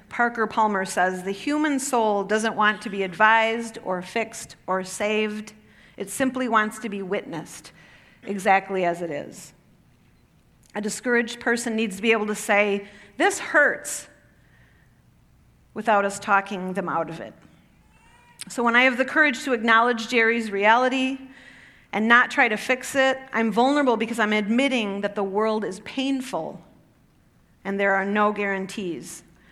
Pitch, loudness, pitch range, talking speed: 215 Hz, -22 LUFS, 200-240 Hz, 150 wpm